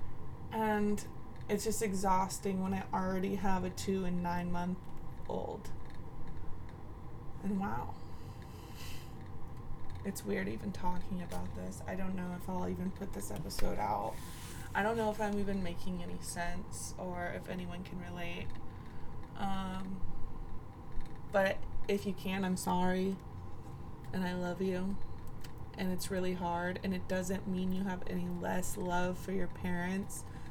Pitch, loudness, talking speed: 180 Hz, -38 LUFS, 145 wpm